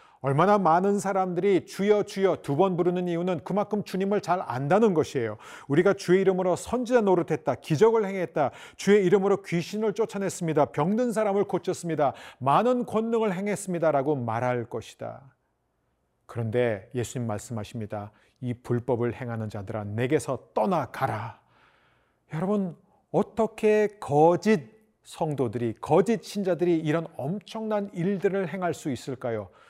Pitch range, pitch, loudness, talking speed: 135-200 Hz, 175 Hz, -26 LUFS, 325 characters per minute